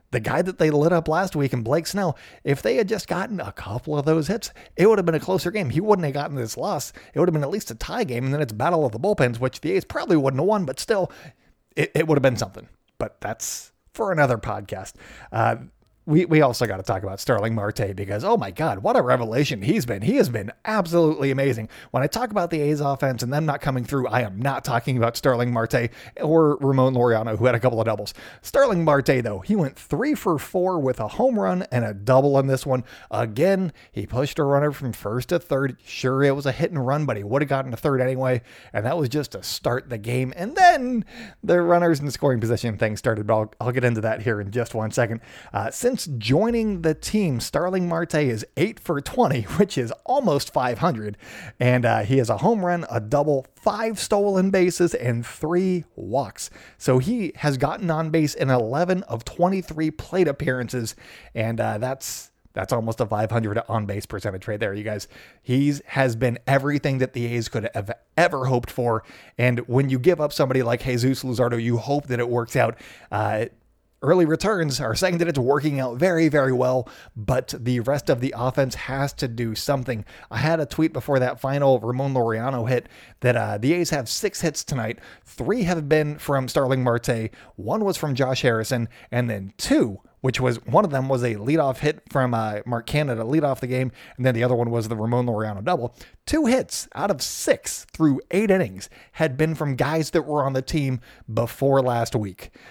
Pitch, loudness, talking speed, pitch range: 130 Hz, -23 LUFS, 220 wpm, 120-155 Hz